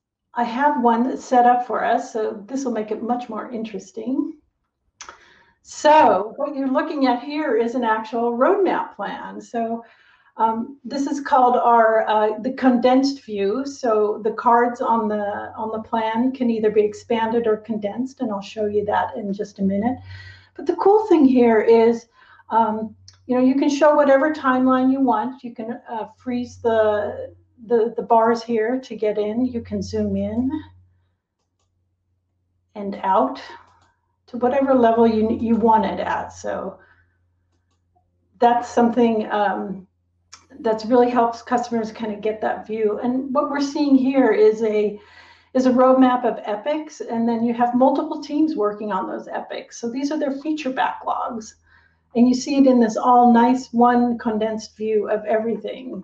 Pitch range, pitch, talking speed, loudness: 215-255 Hz, 230 Hz, 165 wpm, -20 LUFS